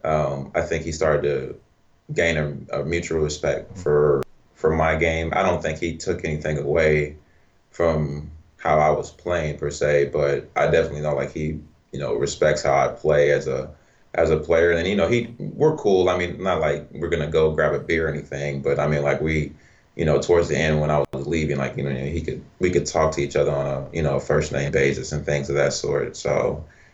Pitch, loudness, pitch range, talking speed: 75 Hz, -22 LUFS, 70-85 Hz, 225 wpm